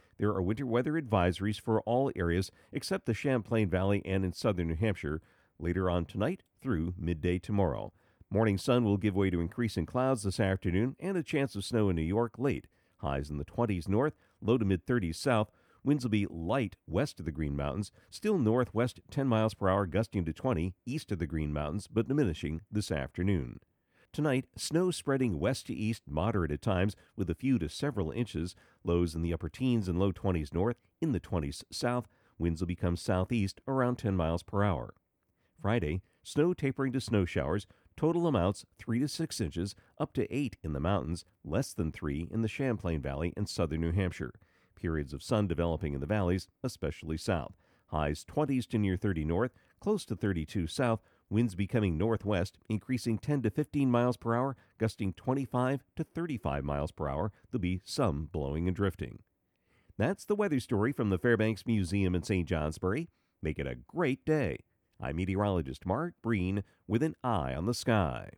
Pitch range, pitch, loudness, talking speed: 85-120 Hz, 100 Hz, -33 LUFS, 185 wpm